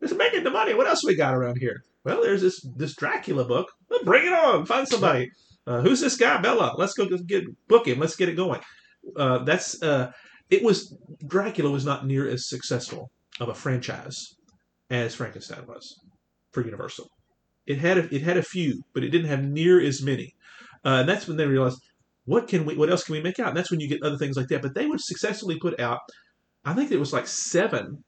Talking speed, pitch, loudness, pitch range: 225 wpm, 160 Hz, -24 LUFS, 135-185 Hz